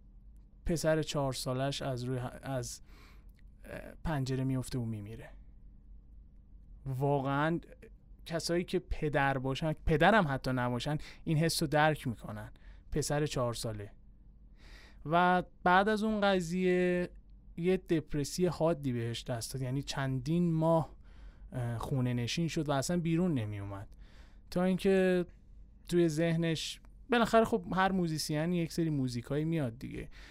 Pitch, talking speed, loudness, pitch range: 145 Hz, 125 wpm, -32 LUFS, 125-170 Hz